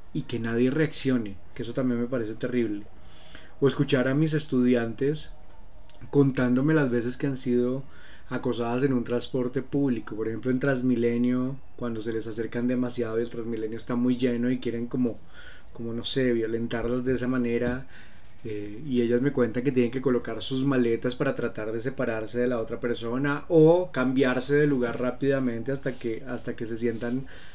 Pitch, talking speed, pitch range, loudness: 125 Hz, 175 wpm, 115-130 Hz, -27 LUFS